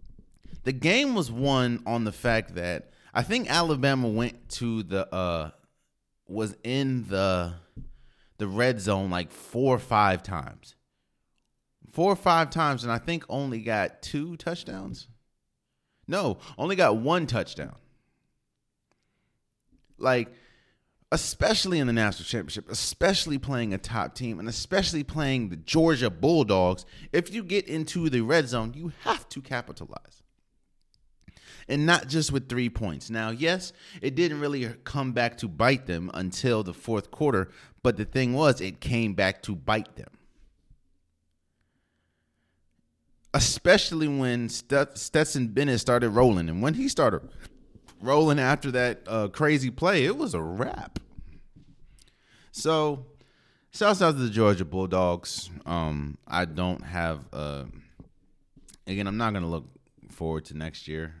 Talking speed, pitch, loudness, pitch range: 140 wpm, 120 Hz, -27 LUFS, 95-140 Hz